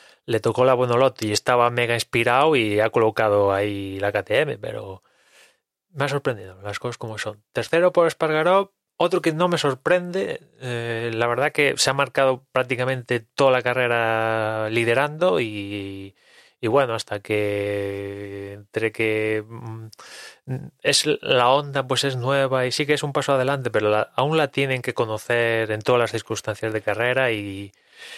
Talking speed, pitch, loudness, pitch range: 160 wpm, 120 Hz, -22 LUFS, 110-135 Hz